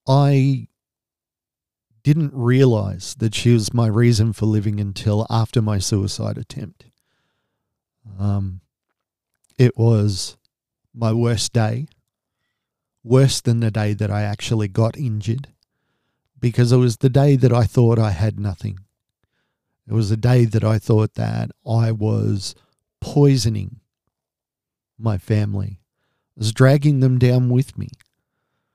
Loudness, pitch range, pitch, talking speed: -19 LUFS, 105-125 Hz, 115 Hz, 125 wpm